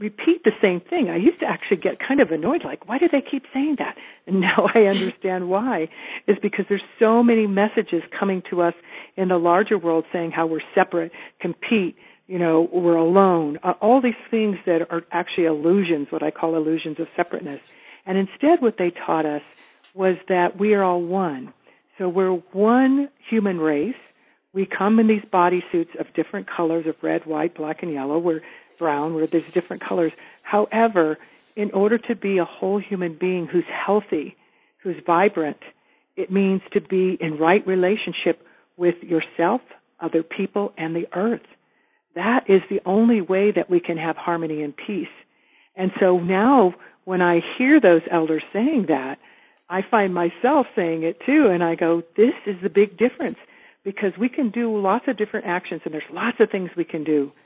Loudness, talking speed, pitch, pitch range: -21 LUFS, 185 wpm, 185 Hz, 170-210 Hz